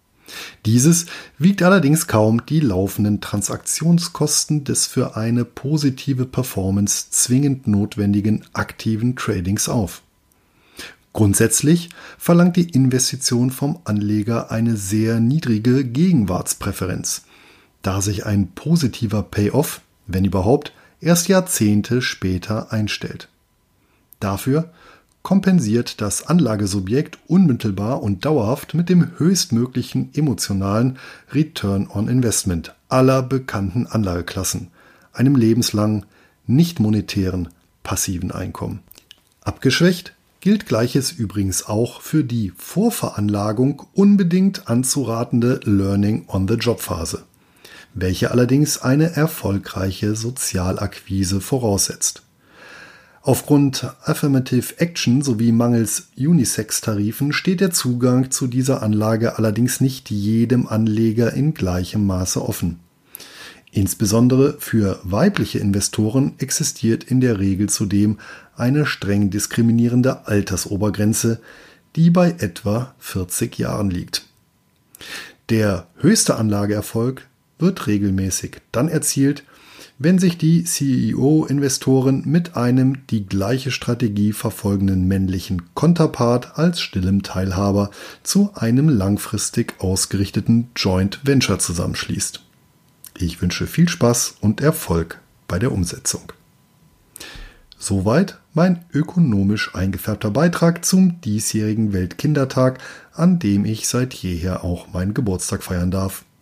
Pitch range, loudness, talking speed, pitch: 100-140 Hz, -19 LUFS, 100 wpm, 115 Hz